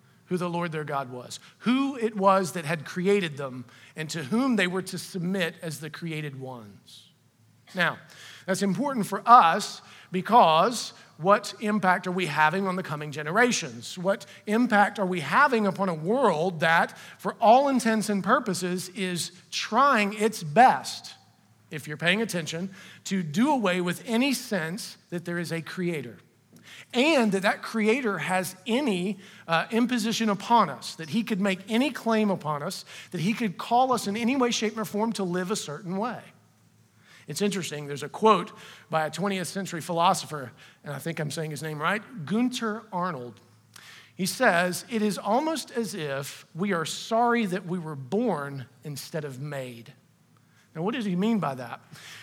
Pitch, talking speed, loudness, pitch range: 185 Hz, 170 wpm, -26 LUFS, 160-215 Hz